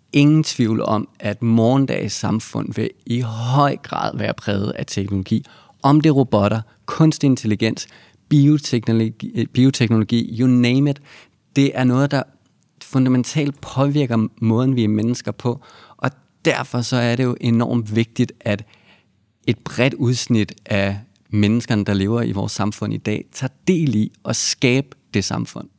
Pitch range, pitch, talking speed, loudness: 110-135 Hz, 120 Hz, 150 wpm, -19 LUFS